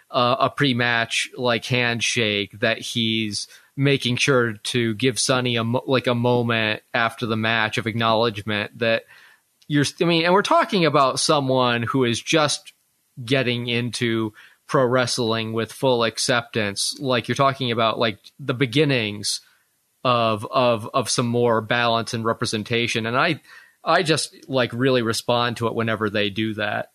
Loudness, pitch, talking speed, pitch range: -21 LUFS, 120 Hz, 150 wpm, 115-130 Hz